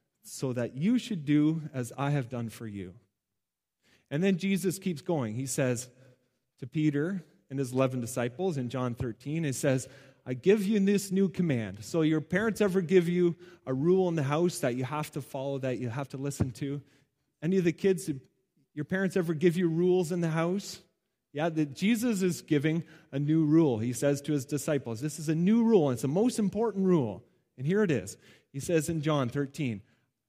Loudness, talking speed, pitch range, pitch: -29 LUFS, 200 wpm, 130-180 Hz, 150 Hz